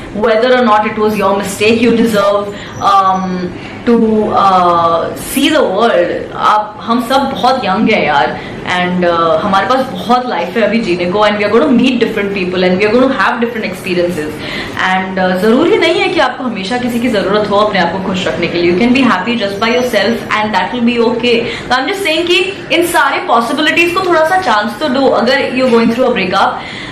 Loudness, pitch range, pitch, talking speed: -11 LUFS, 195-255 Hz, 225 Hz, 200 wpm